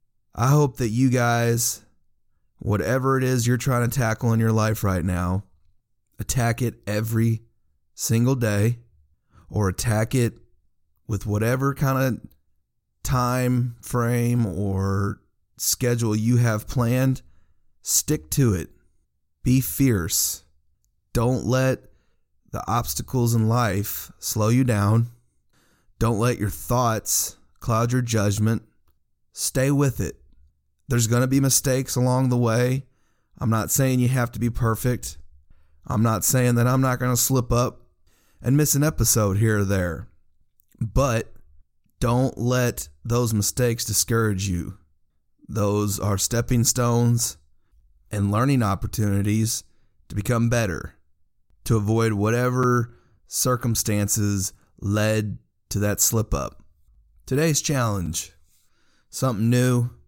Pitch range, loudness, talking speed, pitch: 100-125 Hz, -23 LUFS, 125 wpm, 115 Hz